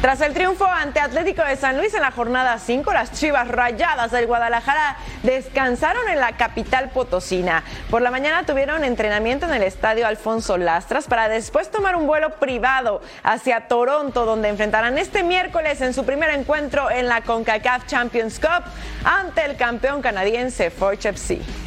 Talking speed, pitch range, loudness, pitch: 165 wpm, 230-295 Hz, -20 LUFS, 250 Hz